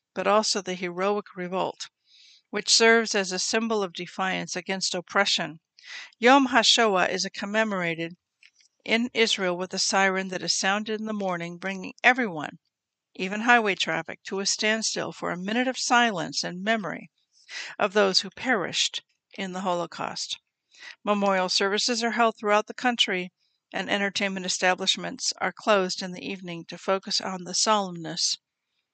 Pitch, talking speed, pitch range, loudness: 195 Hz, 150 wpm, 185-215 Hz, -25 LUFS